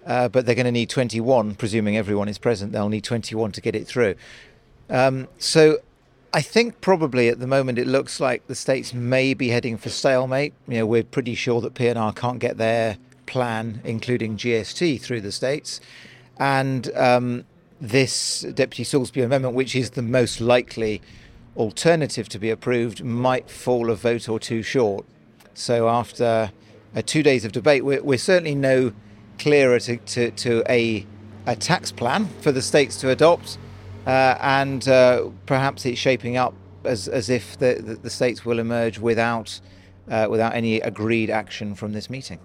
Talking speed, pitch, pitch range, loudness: 170 wpm, 120 Hz, 110-130 Hz, -22 LUFS